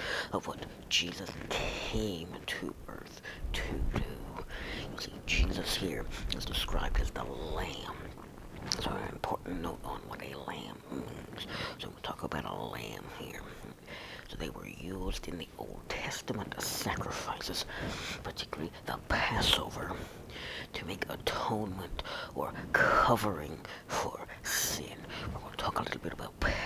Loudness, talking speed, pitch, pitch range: -36 LUFS, 135 wpm, 95 Hz, 85-95 Hz